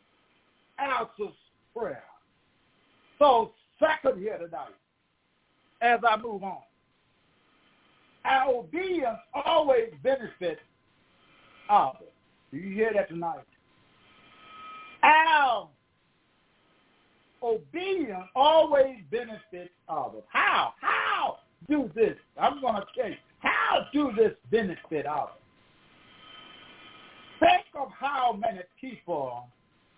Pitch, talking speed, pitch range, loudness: 275 Hz, 85 wpm, 225-365 Hz, -27 LUFS